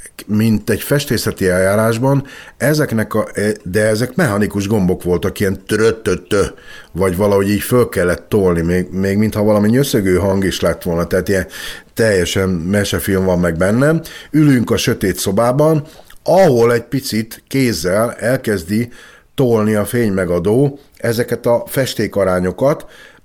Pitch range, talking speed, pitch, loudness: 95-120 Hz, 130 wpm, 105 Hz, -15 LUFS